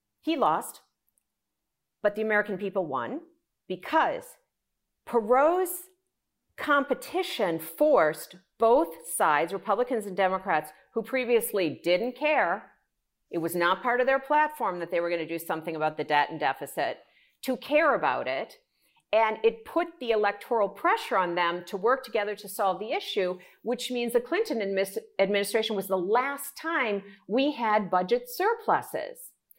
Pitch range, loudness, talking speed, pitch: 185-280 Hz, -27 LUFS, 145 wpm, 220 Hz